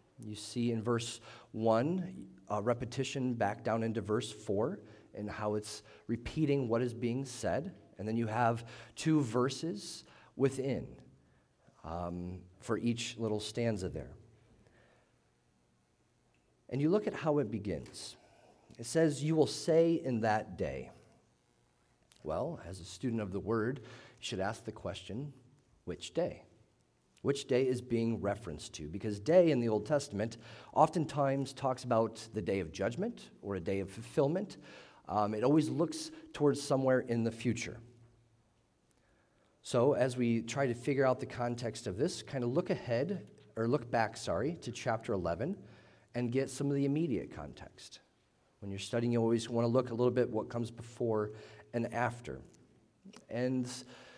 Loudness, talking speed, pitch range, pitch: -35 LUFS, 155 wpm, 110-130 Hz, 120 Hz